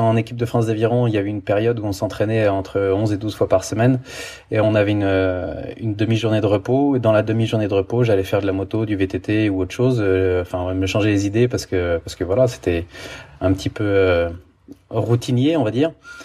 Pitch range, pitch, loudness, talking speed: 95-115 Hz, 105 Hz, -19 LUFS, 240 wpm